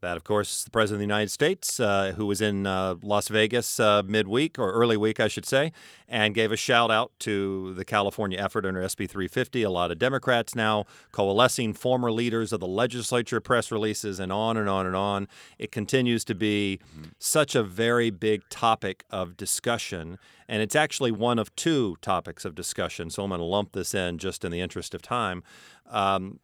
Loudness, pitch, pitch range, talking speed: -26 LUFS, 105 Hz, 95-115 Hz, 200 wpm